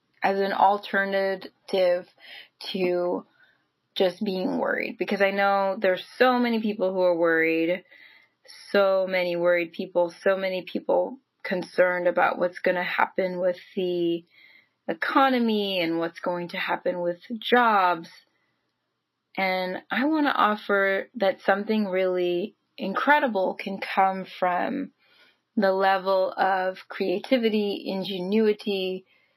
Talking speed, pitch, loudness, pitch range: 115 wpm, 190 Hz, -25 LUFS, 180-205 Hz